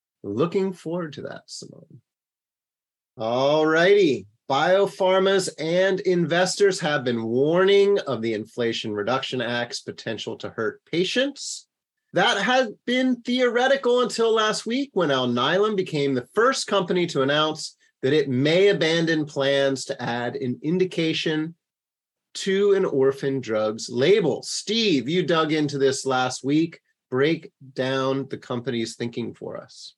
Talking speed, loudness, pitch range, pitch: 130 wpm, -23 LUFS, 135-200 Hz, 160 Hz